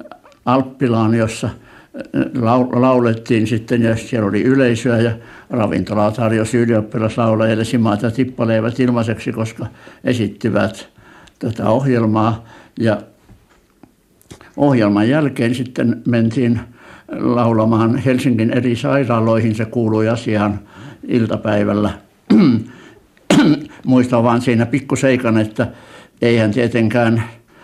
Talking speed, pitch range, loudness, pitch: 85 wpm, 110-125 Hz, -16 LUFS, 115 Hz